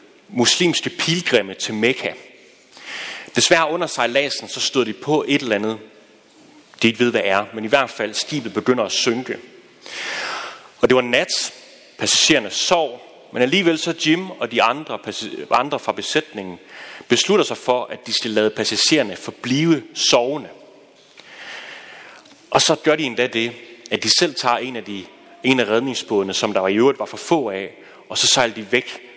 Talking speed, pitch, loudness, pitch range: 170 wpm, 120 Hz, -18 LUFS, 110-150 Hz